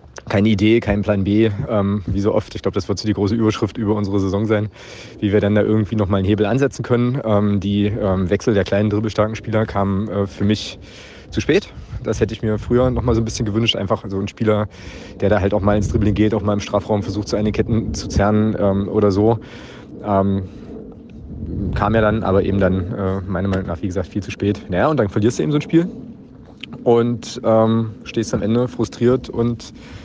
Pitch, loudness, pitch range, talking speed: 105 Hz, -19 LUFS, 100-110 Hz, 225 wpm